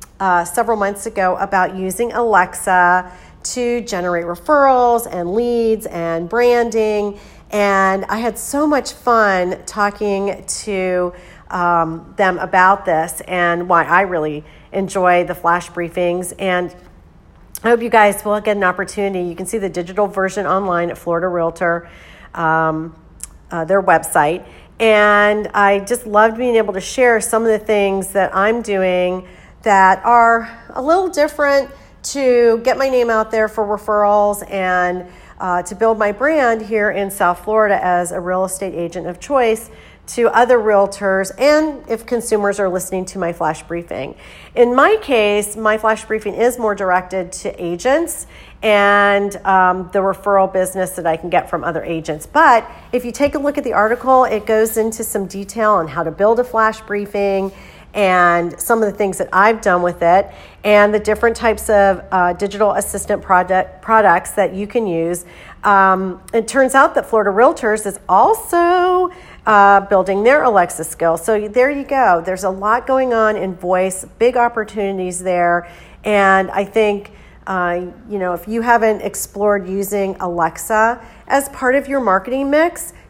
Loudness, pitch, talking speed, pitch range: -16 LUFS, 200 Hz, 165 wpm, 185-225 Hz